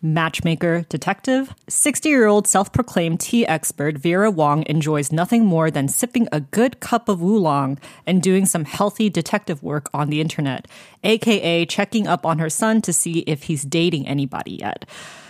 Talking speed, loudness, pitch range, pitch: 170 wpm, -19 LUFS, 155-210 Hz, 170 Hz